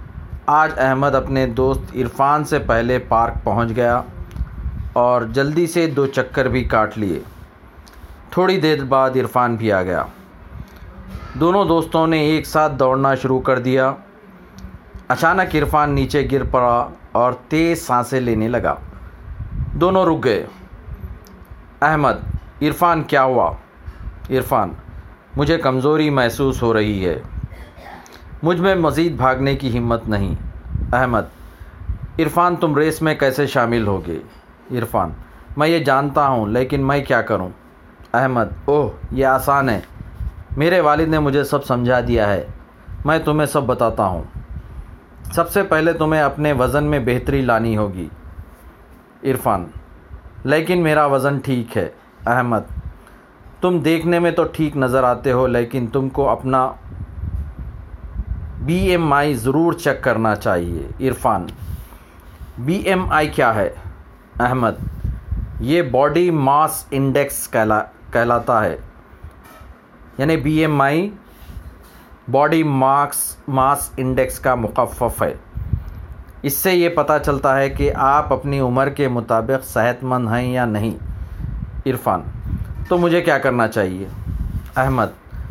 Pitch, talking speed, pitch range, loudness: 130 Hz, 130 wpm, 105-145 Hz, -18 LUFS